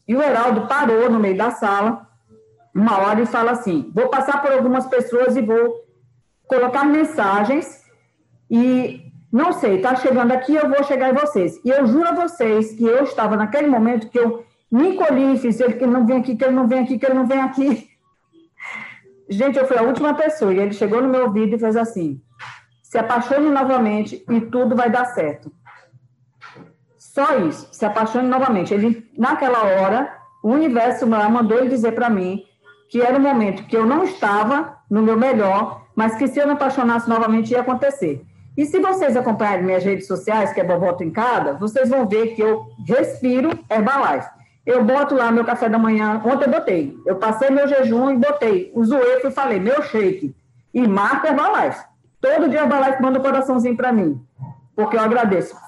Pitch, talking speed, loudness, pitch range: 245 Hz, 190 wpm, -18 LUFS, 215-270 Hz